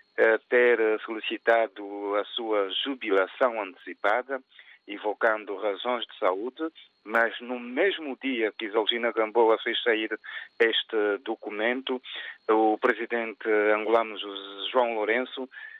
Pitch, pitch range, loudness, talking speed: 110 Hz, 105-125 Hz, -27 LUFS, 100 wpm